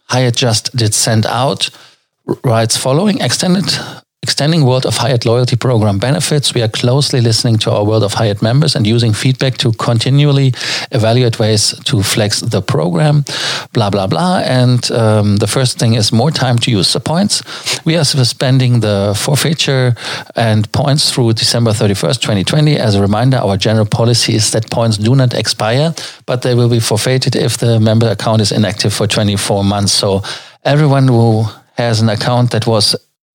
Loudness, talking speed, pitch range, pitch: -12 LUFS, 175 wpm, 110-135 Hz, 120 Hz